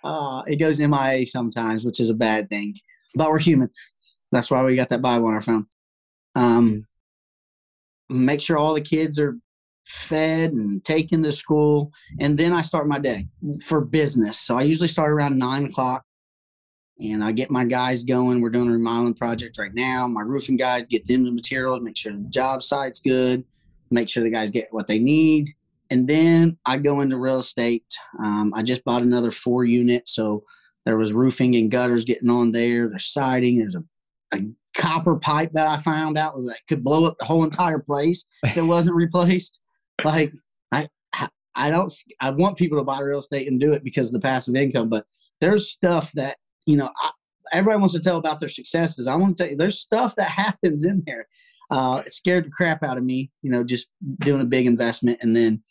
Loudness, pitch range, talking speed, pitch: -21 LUFS, 120-155 Hz, 205 wpm, 130 Hz